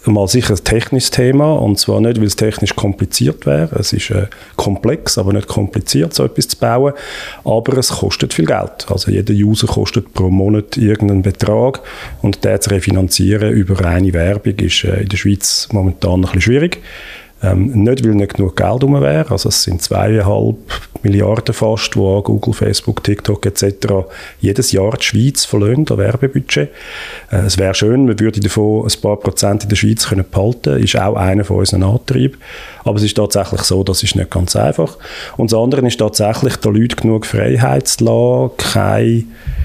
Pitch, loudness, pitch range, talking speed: 105 Hz, -13 LUFS, 100-115 Hz, 185 wpm